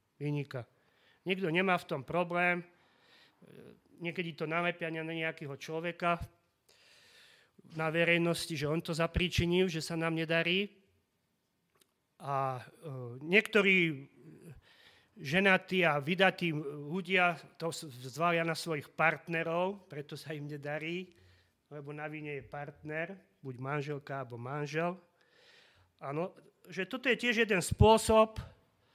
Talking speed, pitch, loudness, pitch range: 110 wpm, 165 Hz, -32 LUFS, 145-180 Hz